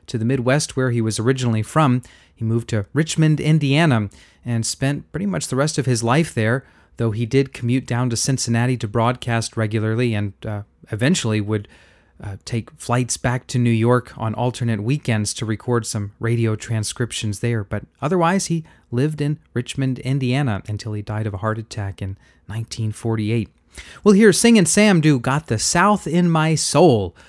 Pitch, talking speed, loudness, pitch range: 120 Hz, 180 wpm, -20 LUFS, 110-140 Hz